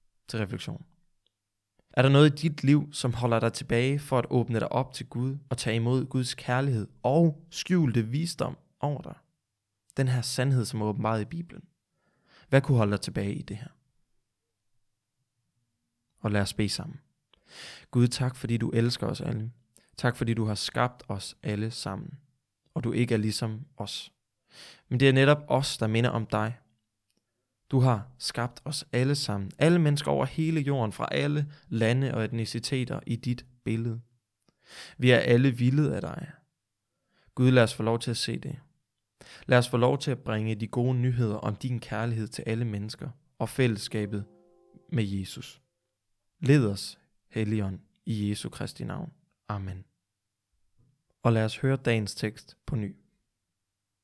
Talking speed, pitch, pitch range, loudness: 165 wpm, 120 Hz, 110-135 Hz, -28 LUFS